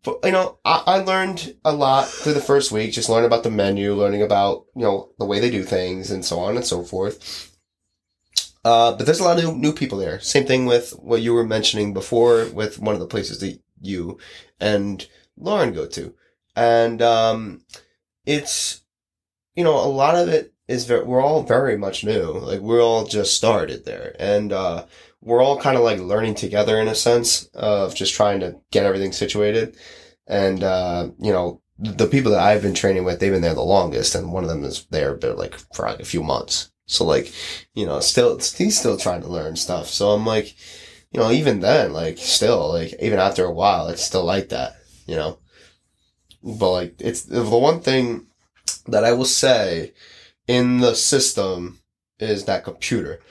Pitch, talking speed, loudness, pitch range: 110 Hz, 200 wpm, -20 LUFS, 100-130 Hz